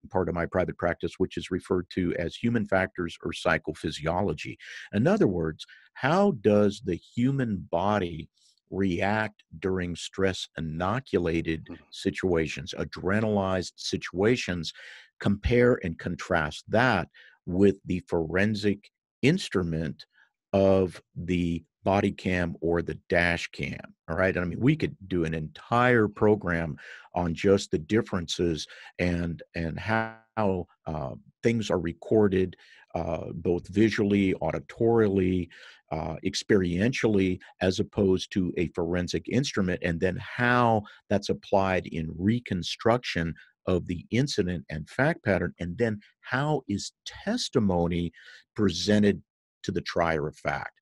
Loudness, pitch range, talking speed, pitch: -27 LUFS, 85-105 Hz, 120 wpm, 95 Hz